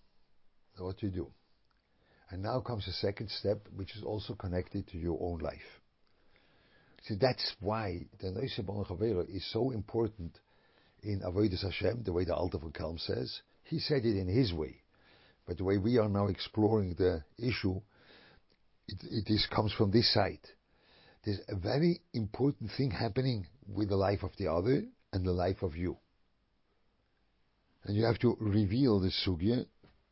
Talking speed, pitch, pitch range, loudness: 160 wpm, 100 Hz, 95-115 Hz, -34 LUFS